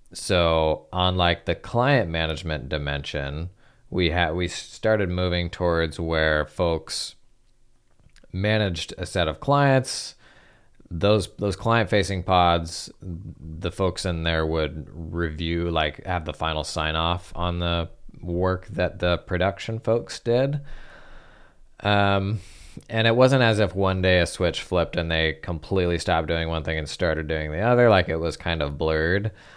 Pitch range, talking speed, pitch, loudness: 80-100 Hz, 150 wpm, 90 Hz, -24 LUFS